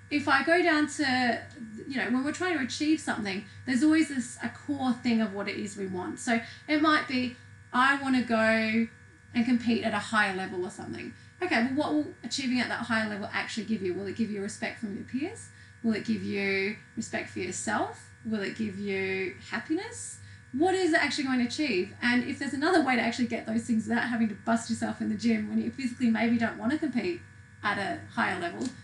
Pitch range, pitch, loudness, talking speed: 215-275 Hz, 235 Hz, -29 LUFS, 230 wpm